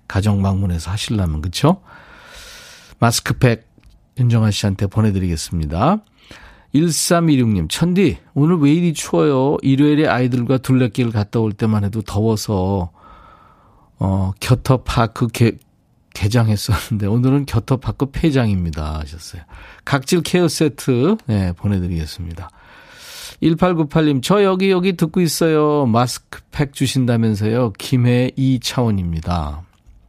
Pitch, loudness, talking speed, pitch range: 120 Hz, -17 LUFS, 265 characters per minute, 100-150 Hz